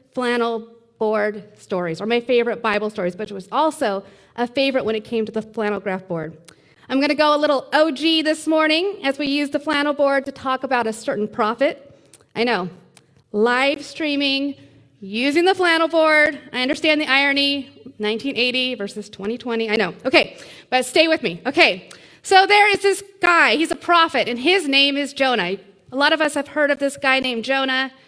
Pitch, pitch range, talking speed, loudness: 260 Hz, 220-300 Hz, 190 wpm, -19 LUFS